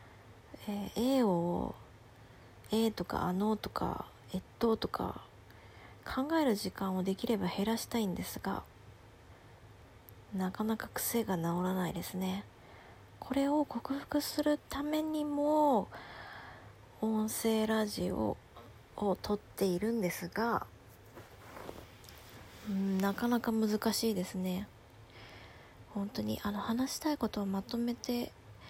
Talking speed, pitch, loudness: 215 characters per minute, 195 Hz, -35 LUFS